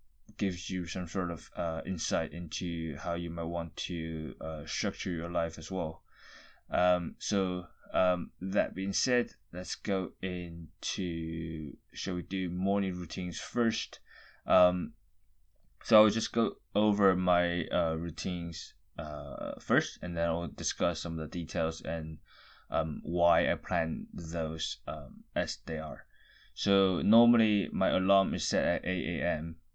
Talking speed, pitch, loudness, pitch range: 145 wpm, 90 Hz, -32 LUFS, 85-95 Hz